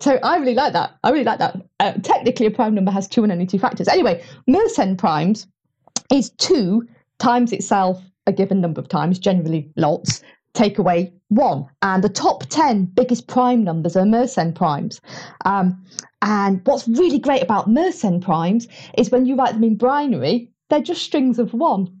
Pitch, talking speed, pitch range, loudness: 210 Hz, 185 wpm, 185-250 Hz, -18 LUFS